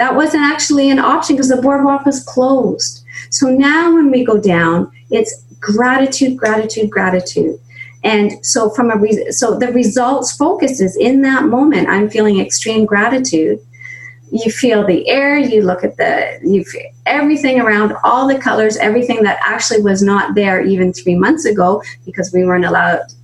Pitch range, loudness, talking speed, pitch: 190-265 Hz, -13 LUFS, 170 wpm, 225 Hz